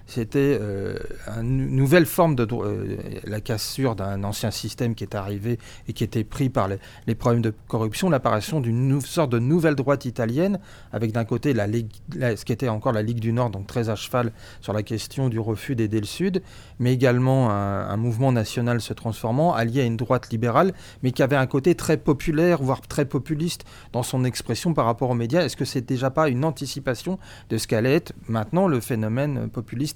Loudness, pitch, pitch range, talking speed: -24 LUFS, 120 Hz, 110-140 Hz, 210 wpm